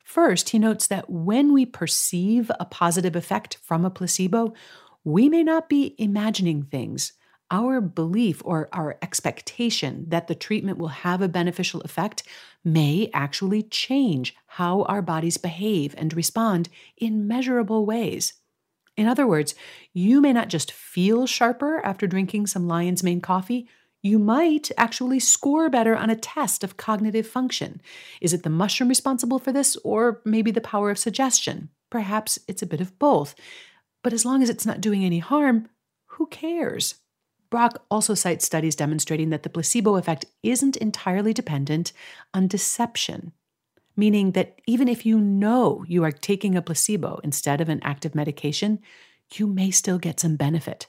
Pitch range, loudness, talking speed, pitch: 170-235 Hz, -23 LUFS, 160 wpm, 205 Hz